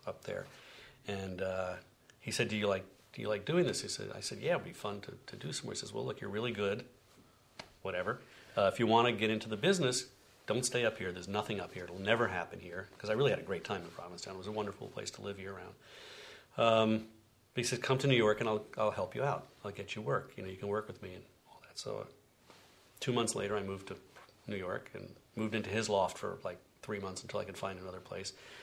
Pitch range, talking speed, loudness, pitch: 95-115 Hz, 260 wpm, -36 LUFS, 105 Hz